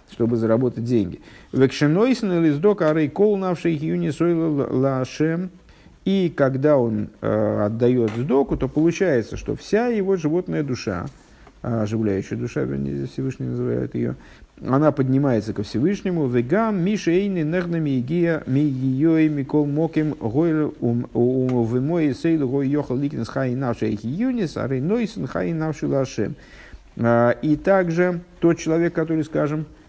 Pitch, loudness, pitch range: 145 Hz, -21 LUFS, 120-165 Hz